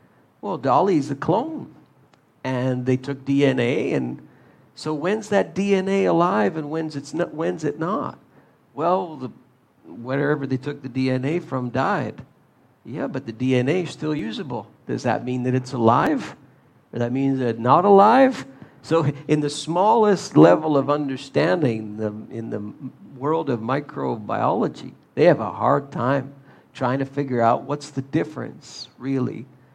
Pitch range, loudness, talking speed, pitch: 125-150 Hz, -22 LUFS, 155 wpm, 135 Hz